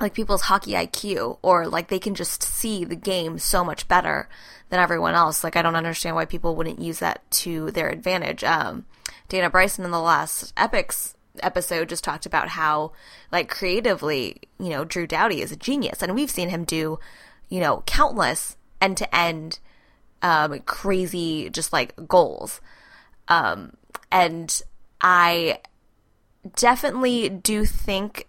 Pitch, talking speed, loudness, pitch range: 175 Hz, 155 wpm, -23 LUFS, 165-190 Hz